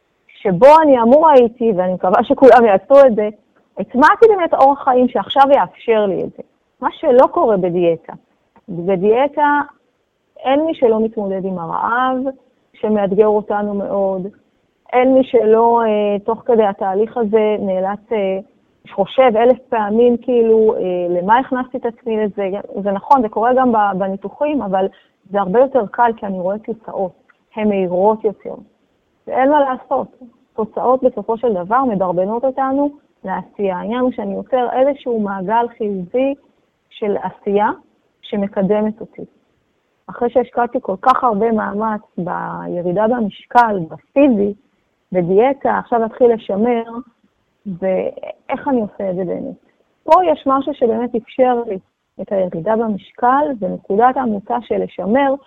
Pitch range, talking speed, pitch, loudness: 200-255 Hz, 130 wpm, 230 Hz, -15 LUFS